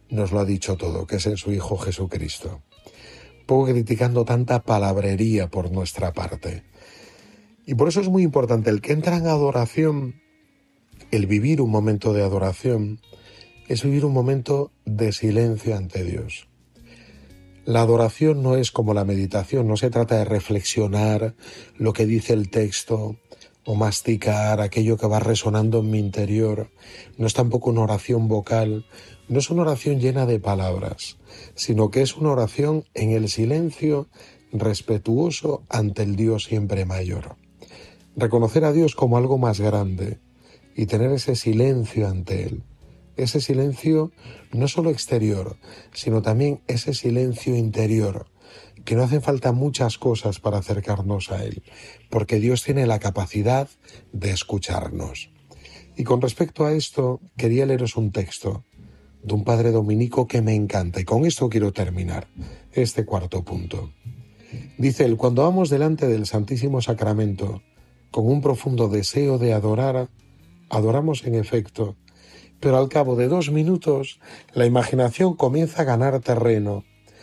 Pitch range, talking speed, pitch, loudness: 105-130 Hz, 145 wpm, 110 Hz, -22 LUFS